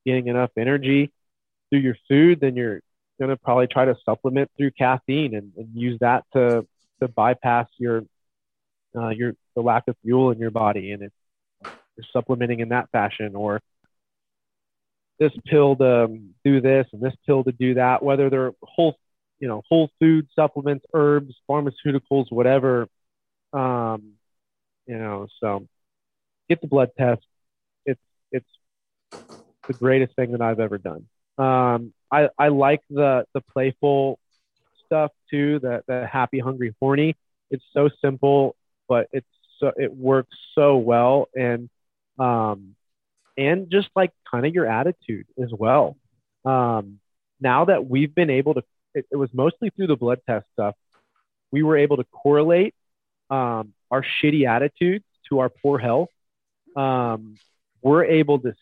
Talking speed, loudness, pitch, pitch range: 155 wpm, -21 LUFS, 130 Hz, 115-140 Hz